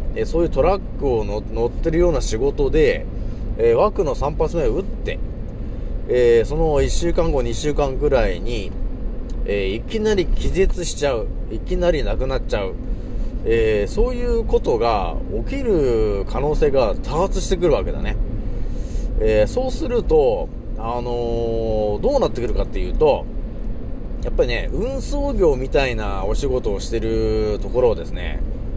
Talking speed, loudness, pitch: 300 characters per minute, -21 LUFS, 140 Hz